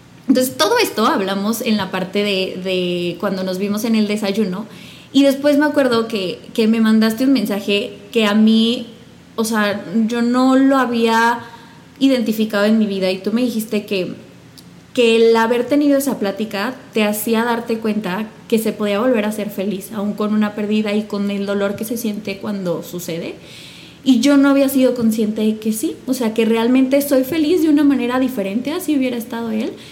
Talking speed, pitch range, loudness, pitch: 195 wpm, 205-250 Hz, -17 LUFS, 225 Hz